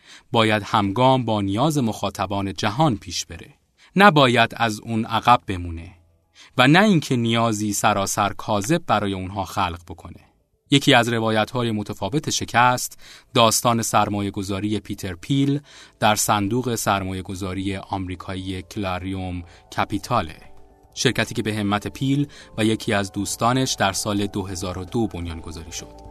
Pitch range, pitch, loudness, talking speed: 95-120 Hz, 105 Hz, -21 LUFS, 130 wpm